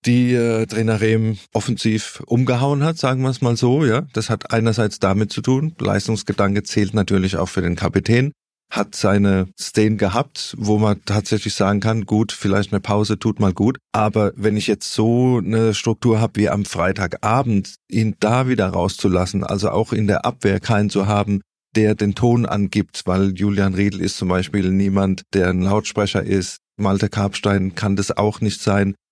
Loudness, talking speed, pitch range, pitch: -19 LUFS, 180 wpm, 100-115 Hz, 105 Hz